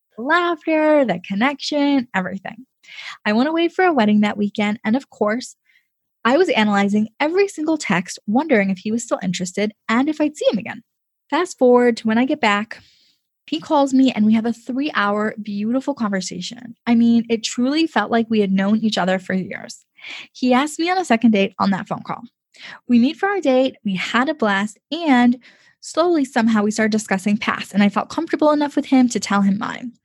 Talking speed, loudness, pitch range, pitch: 200 wpm, -19 LUFS, 210-280 Hz, 235 Hz